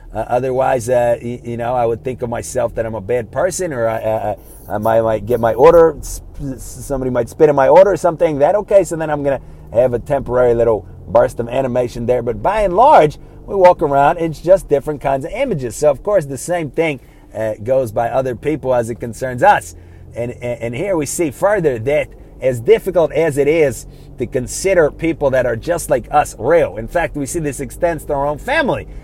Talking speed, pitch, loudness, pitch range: 225 wpm, 135 Hz, -16 LUFS, 120-165 Hz